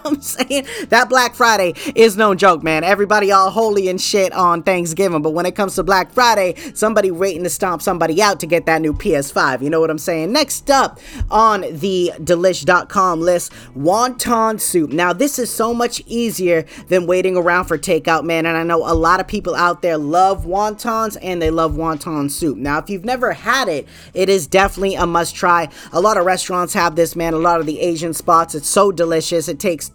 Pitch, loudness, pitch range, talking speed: 180 Hz, -16 LUFS, 165-210 Hz, 210 wpm